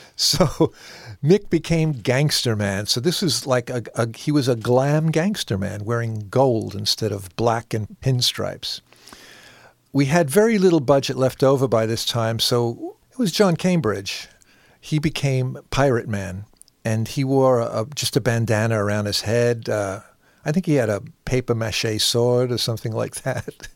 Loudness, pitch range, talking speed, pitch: -21 LUFS, 110-145 Hz, 165 wpm, 125 Hz